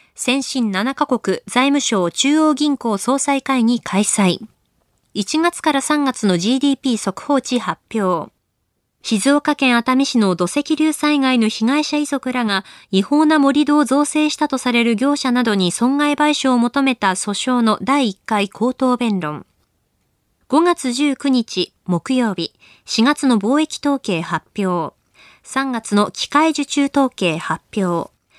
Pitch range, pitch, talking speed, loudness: 205-285 Hz, 250 Hz, 235 characters per minute, -17 LUFS